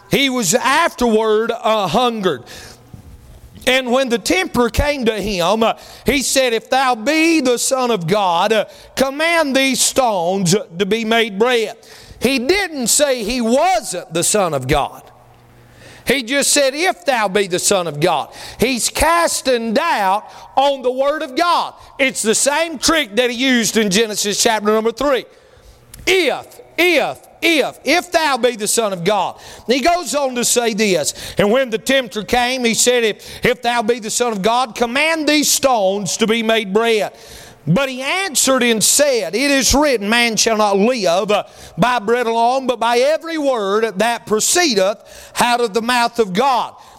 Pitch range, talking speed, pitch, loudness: 220-275 Hz, 170 wpm, 240 Hz, -16 LUFS